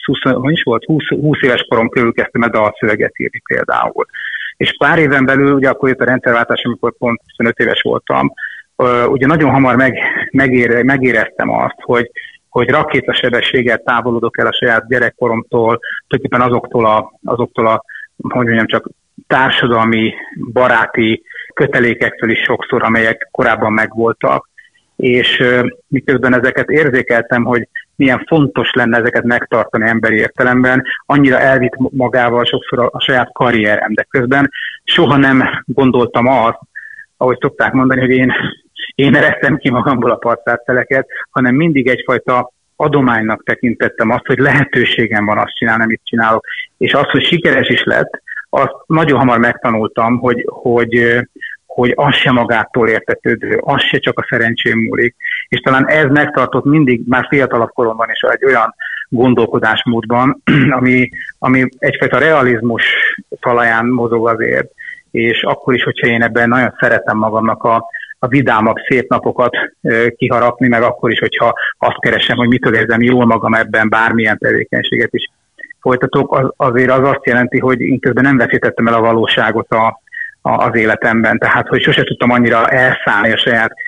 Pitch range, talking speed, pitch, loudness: 115-135 Hz, 145 wpm, 125 Hz, -12 LUFS